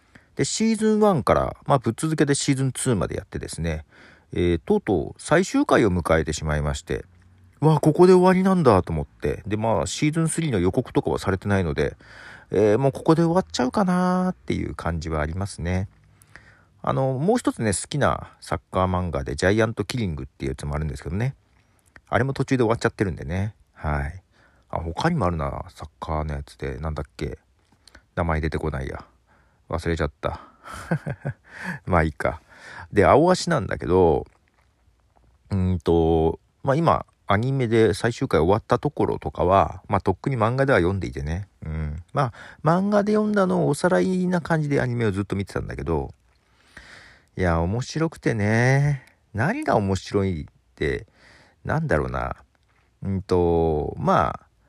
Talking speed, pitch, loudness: 345 characters per minute, 100 Hz, -23 LUFS